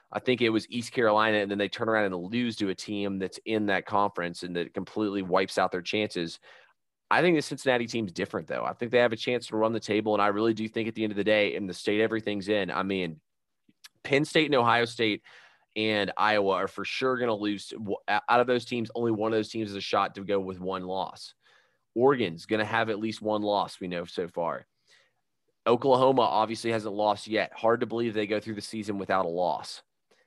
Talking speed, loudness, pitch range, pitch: 235 wpm, -28 LUFS, 100-115 Hz, 105 Hz